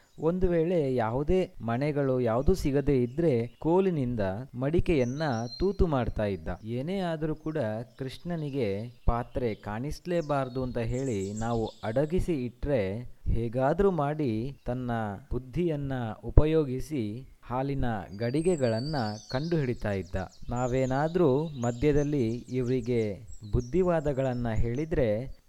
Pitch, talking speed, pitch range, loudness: 130 Hz, 85 wpm, 115-150 Hz, -29 LUFS